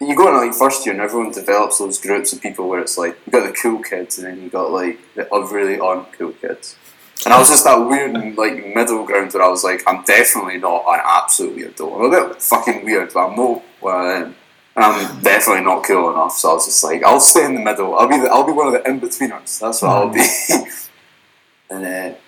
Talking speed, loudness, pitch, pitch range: 255 wpm, -14 LUFS, 100 Hz, 95-115 Hz